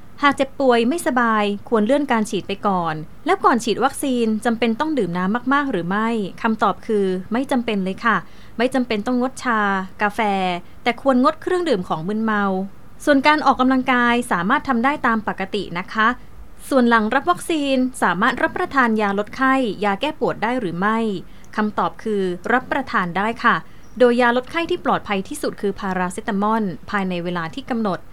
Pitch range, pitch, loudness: 200-260 Hz, 230 Hz, -20 LUFS